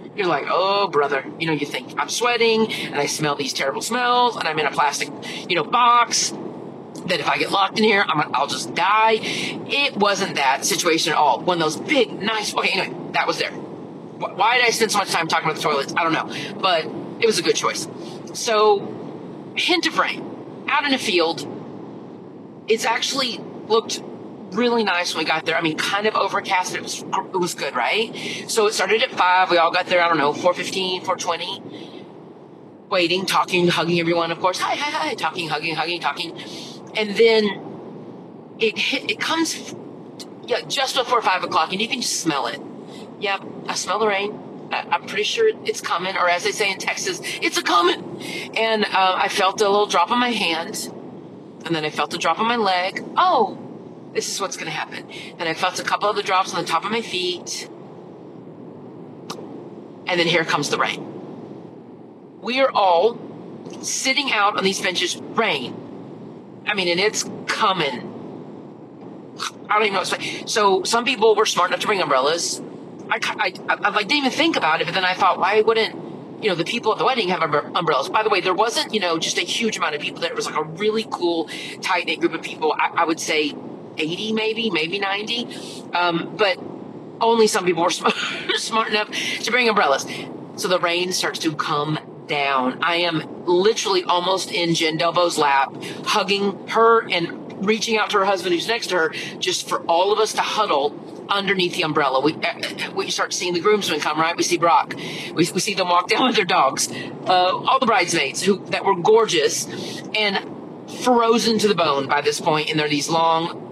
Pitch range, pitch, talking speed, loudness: 175-225 Hz, 195 Hz, 205 wpm, -20 LUFS